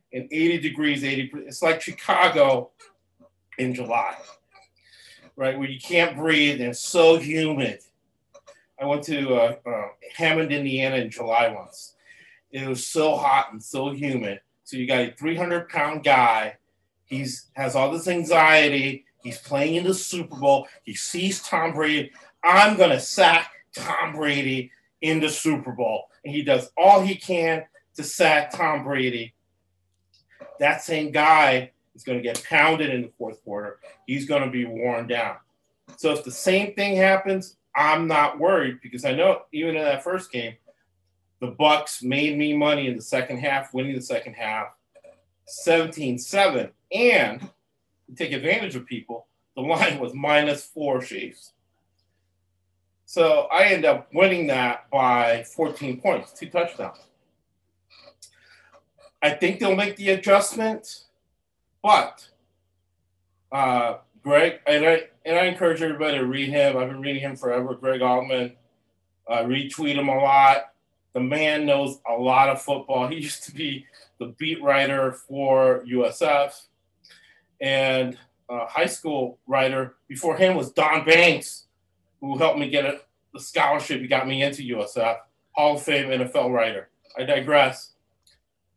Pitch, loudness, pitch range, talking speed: 135 Hz, -22 LUFS, 120-155 Hz, 155 wpm